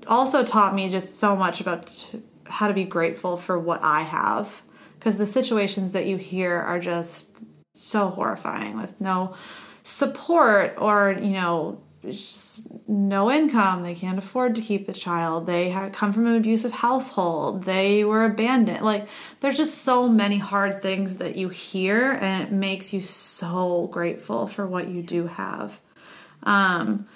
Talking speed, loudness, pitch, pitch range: 160 wpm, -23 LUFS, 195 Hz, 180-220 Hz